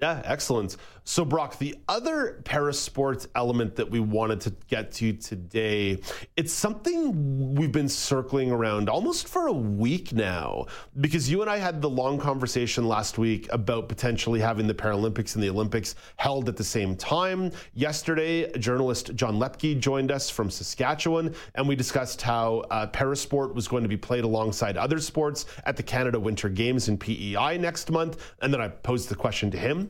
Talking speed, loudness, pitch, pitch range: 175 wpm, -27 LUFS, 125 Hz, 110-145 Hz